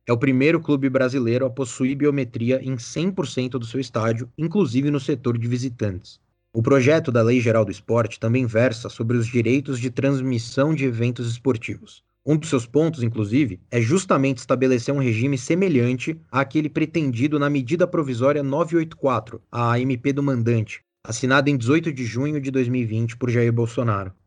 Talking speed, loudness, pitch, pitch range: 165 wpm, -22 LUFS, 130 Hz, 120-140 Hz